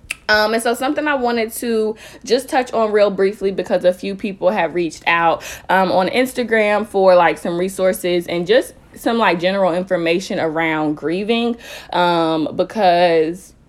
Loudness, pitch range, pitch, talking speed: -17 LUFS, 175-225 Hz, 190 Hz, 160 wpm